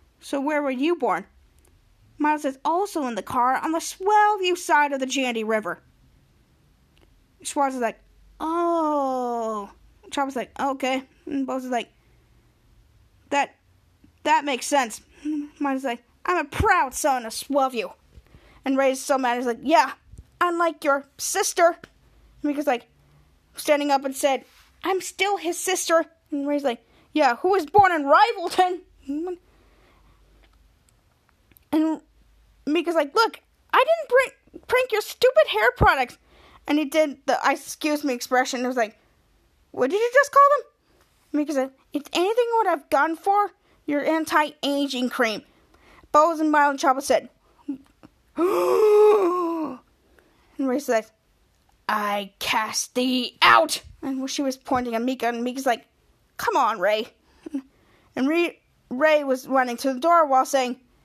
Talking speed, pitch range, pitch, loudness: 145 wpm, 260-335 Hz, 290 Hz, -23 LUFS